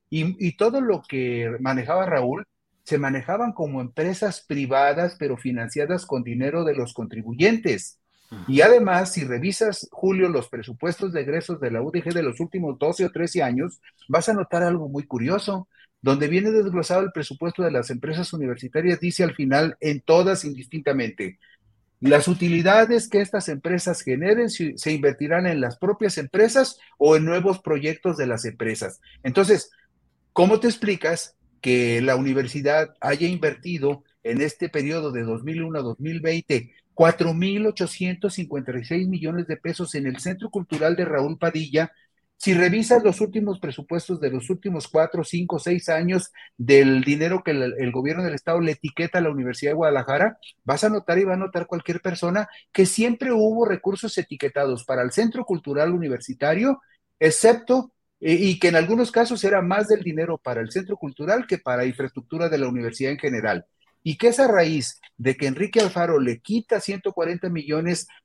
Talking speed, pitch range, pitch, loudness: 165 wpm, 140-190 Hz, 165 Hz, -22 LUFS